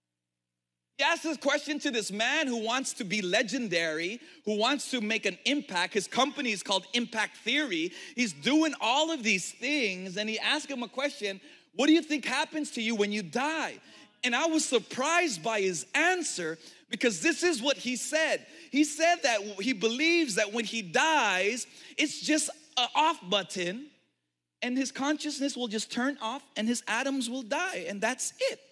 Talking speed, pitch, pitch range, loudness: 185 wpm, 250 Hz, 210-300 Hz, -29 LUFS